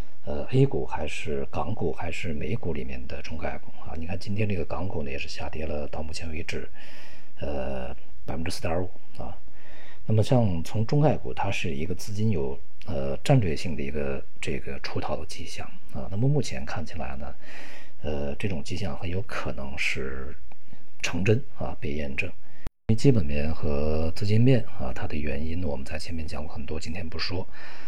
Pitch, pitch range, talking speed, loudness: 85 Hz, 75-100 Hz, 270 characters per minute, -29 LUFS